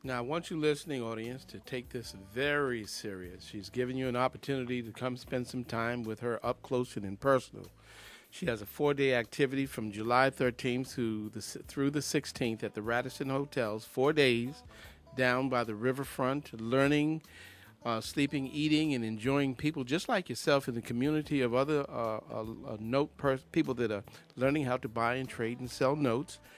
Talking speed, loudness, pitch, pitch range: 185 wpm, -33 LUFS, 130 Hz, 115-140 Hz